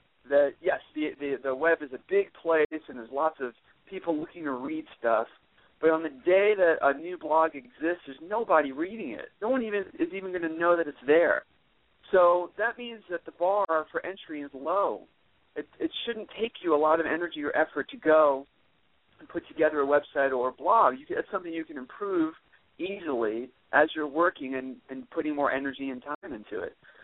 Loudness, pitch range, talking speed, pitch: -28 LUFS, 145-205 Hz, 210 wpm, 160 Hz